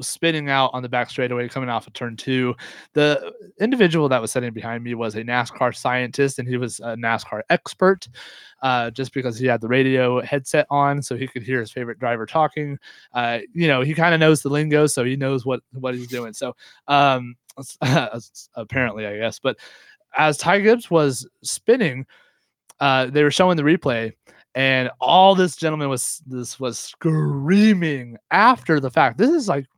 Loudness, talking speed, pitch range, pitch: -20 LUFS, 185 wpm, 125-155 Hz, 130 Hz